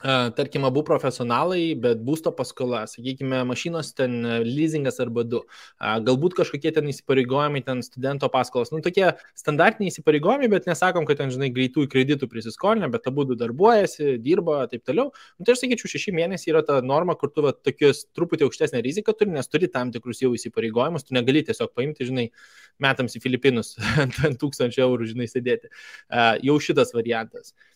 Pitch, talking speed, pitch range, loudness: 140 Hz, 170 wpm, 125-165 Hz, -23 LUFS